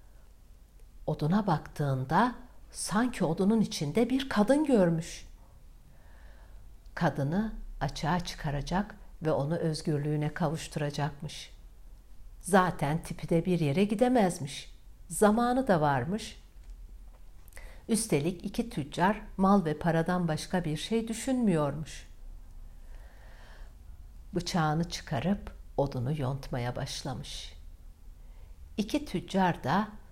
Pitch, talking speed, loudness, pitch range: 160 Hz, 85 wpm, -30 LUFS, 135-195 Hz